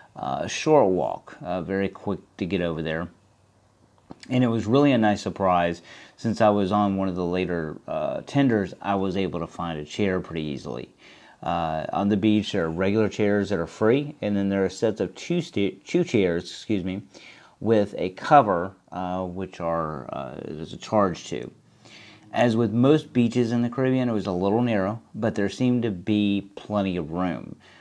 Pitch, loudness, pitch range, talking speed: 100 Hz, -25 LUFS, 90-110 Hz, 195 wpm